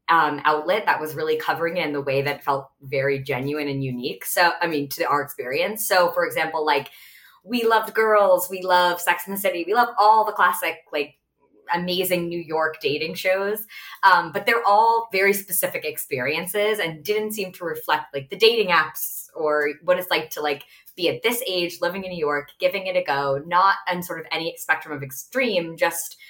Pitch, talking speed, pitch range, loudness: 175 Hz, 205 wpm, 150-200 Hz, -22 LUFS